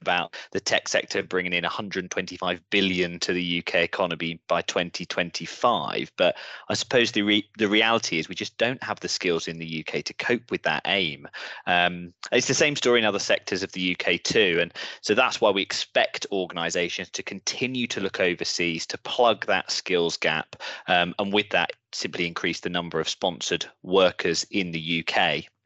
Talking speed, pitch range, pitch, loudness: 185 wpm, 85-105 Hz, 90 Hz, -25 LUFS